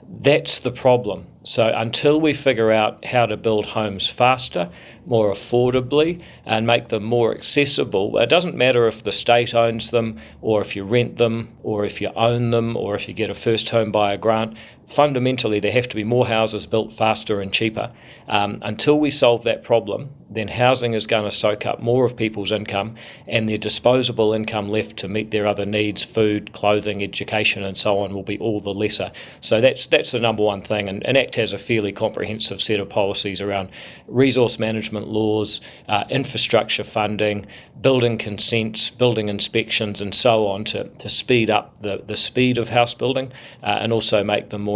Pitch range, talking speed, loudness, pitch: 105-120 Hz, 190 wpm, -19 LUFS, 110 Hz